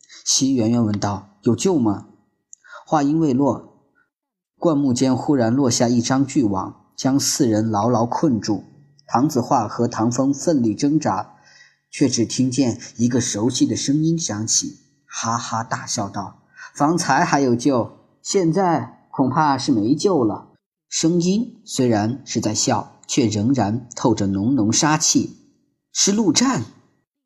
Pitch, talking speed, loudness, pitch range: 130 Hz, 200 characters per minute, -19 LUFS, 115-150 Hz